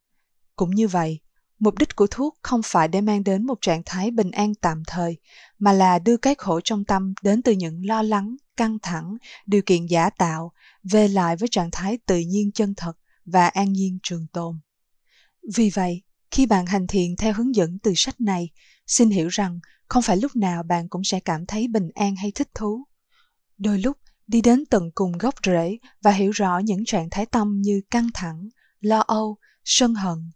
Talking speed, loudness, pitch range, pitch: 200 wpm, -22 LUFS, 180-220 Hz, 200 Hz